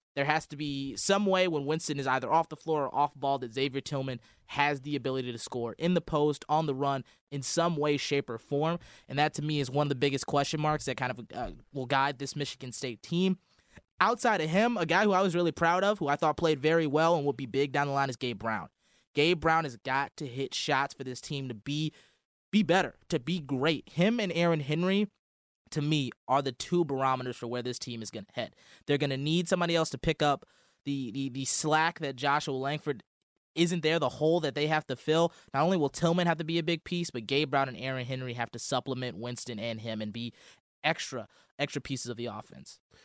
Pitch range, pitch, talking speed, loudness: 130-160 Hz, 145 Hz, 245 wpm, -30 LUFS